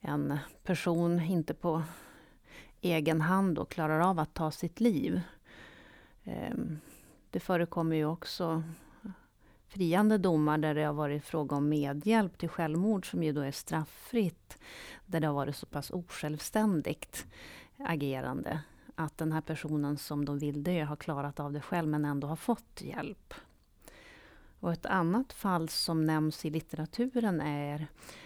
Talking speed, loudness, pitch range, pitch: 140 wpm, -33 LUFS, 150-175 Hz, 160 Hz